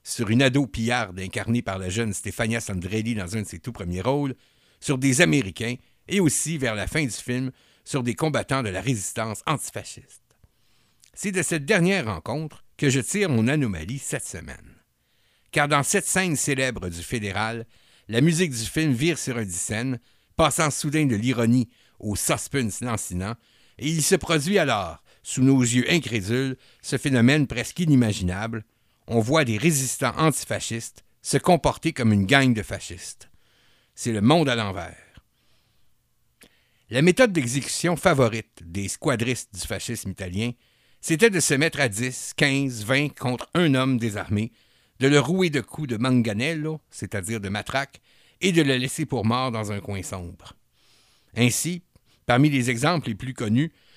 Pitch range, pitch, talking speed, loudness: 110-145 Hz, 125 Hz, 160 wpm, -23 LUFS